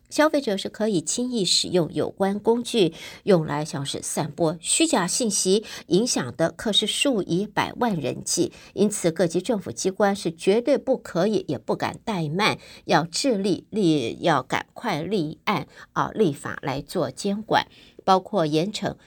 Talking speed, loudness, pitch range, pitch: 235 characters per minute, -24 LUFS, 170-230 Hz, 200 Hz